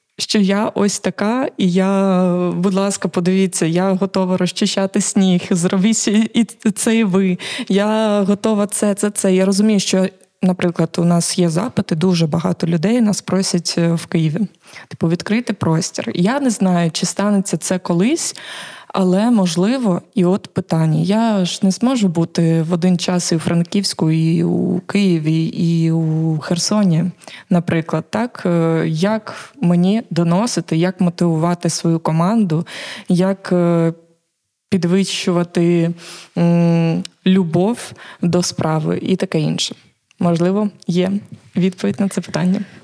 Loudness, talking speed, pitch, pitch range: -17 LUFS, 130 wpm, 185 Hz, 170-200 Hz